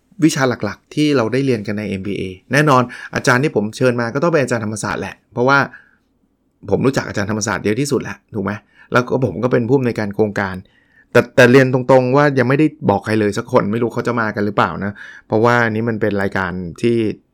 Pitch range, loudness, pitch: 105-130 Hz, -17 LUFS, 115 Hz